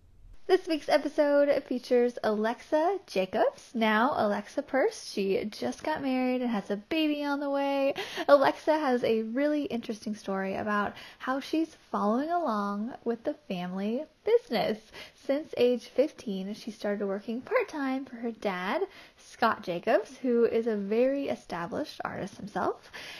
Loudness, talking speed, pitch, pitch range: -29 LUFS, 140 wpm, 250 Hz, 215-295 Hz